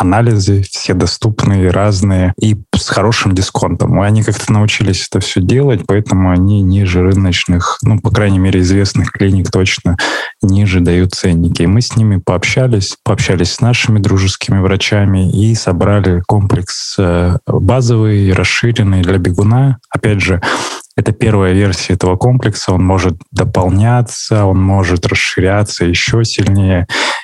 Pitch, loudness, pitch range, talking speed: 100 Hz, -12 LUFS, 95-110 Hz, 130 wpm